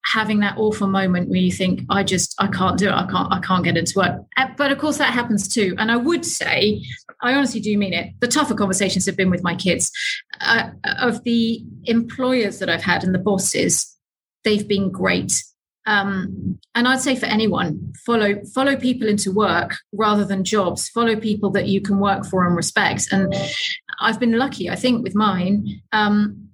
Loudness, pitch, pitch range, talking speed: -19 LUFS, 210 Hz, 190-235 Hz, 215 wpm